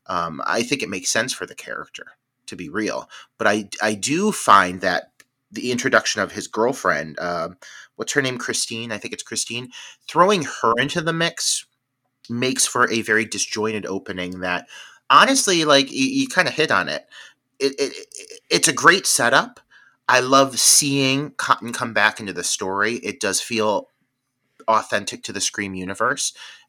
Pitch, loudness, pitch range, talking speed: 125 Hz, -19 LUFS, 105-145 Hz, 175 wpm